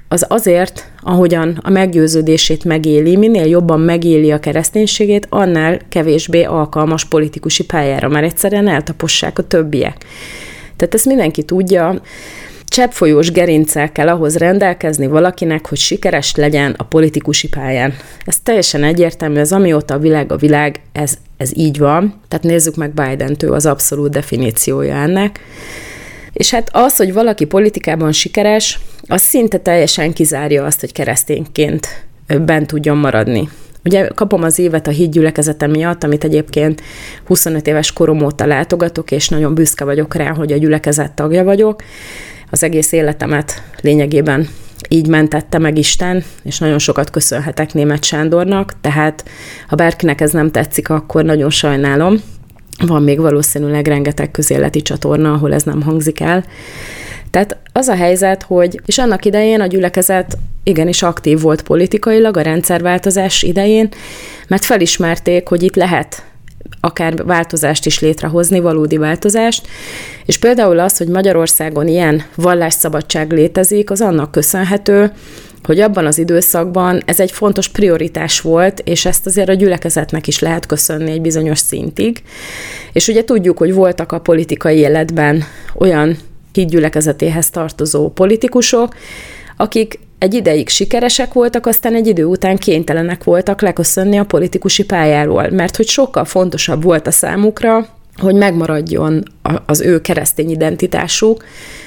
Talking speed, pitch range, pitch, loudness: 135 wpm, 150-185 Hz, 160 Hz, -12 LUFS